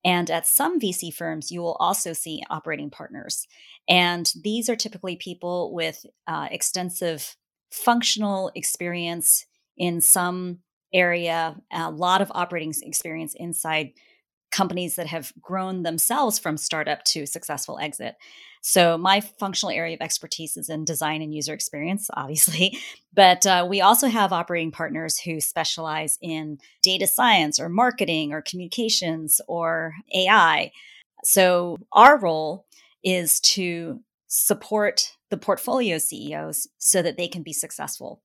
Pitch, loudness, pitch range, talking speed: 175 Hz, -22 LUFS, 160-190 Hz, 135 wpm